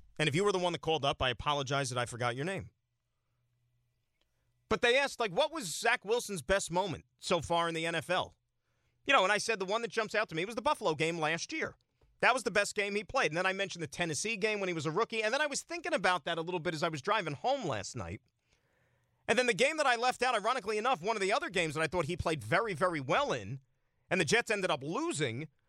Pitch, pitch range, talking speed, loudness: 180 Hz, 150-220 Hz, 270 wpm, -32 LUFS